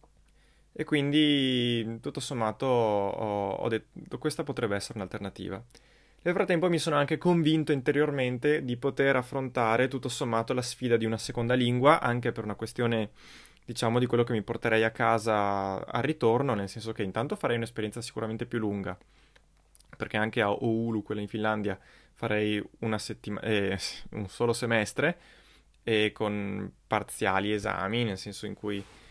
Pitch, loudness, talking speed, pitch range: 115 Hz, -29 LUFS, 155 wpm, 105-130 Hz